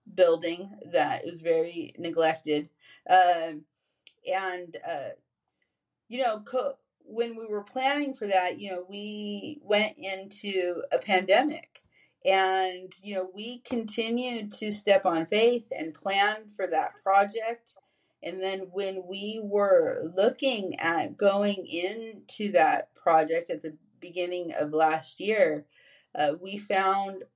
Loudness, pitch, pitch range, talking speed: -28 LUFS, 200 Hz, 180-225 Hz, 125 wpm